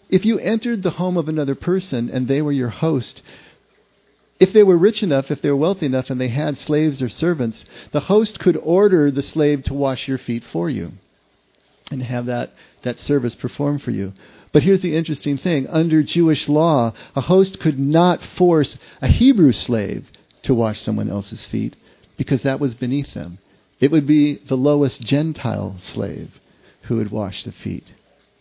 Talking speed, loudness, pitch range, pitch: 185 wpm, -19 LUFS, 120-160 Hz, 140 Hz